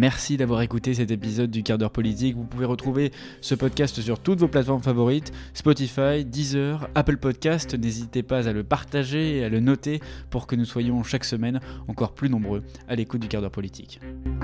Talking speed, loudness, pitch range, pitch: 195 wpm, -25 LUFS, 115-140 Hz, 125 Hz